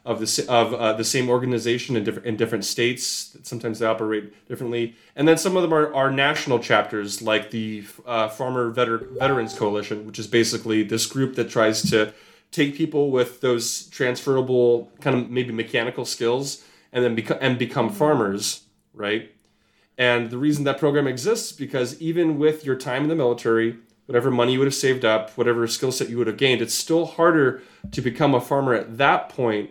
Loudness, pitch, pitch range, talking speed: -22 LUFS, 120 Hz, 115-135 Hz, 195 wpm